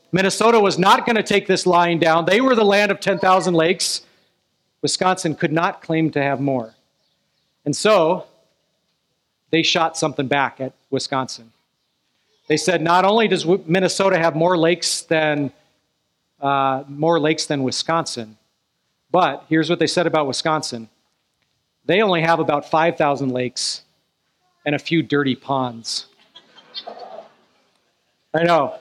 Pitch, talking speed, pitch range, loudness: 160 Hz, 135 wpm, 140-180 Hz, -18 LUFS